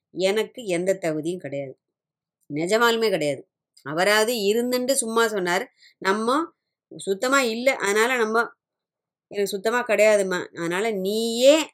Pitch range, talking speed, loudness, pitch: 185-235 Hz, 100 wpm, -22 LUFS, 215 Hz